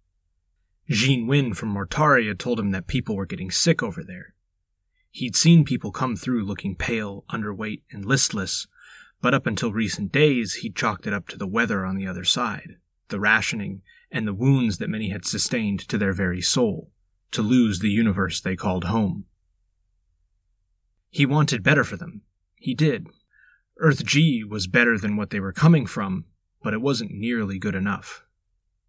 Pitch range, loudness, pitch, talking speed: 95-125 Hz, -23 LUFS, 105 Hz, 170 wpm